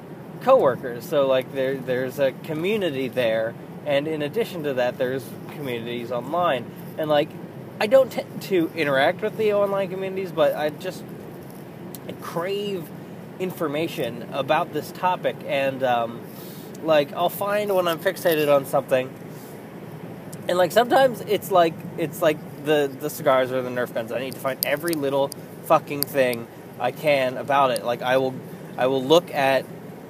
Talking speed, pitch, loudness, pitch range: 155 wpm, 160 Hz, -23 LUFS, 135-185 Hz